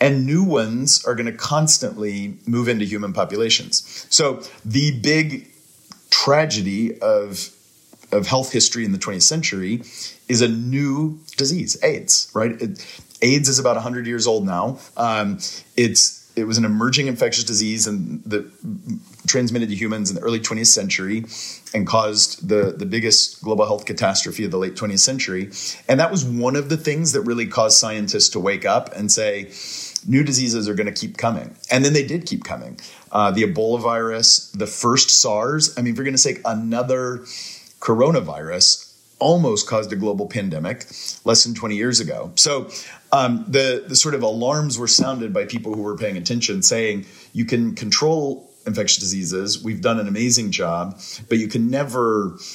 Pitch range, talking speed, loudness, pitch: 110-135 Hz, 170 wpm, -18 LUFS, 120 Hz